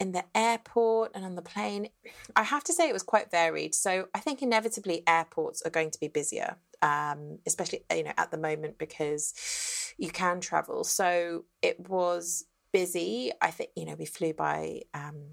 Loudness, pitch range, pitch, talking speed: -30 LUFS, 160-220 Hz, 175 Hz, 190 wpm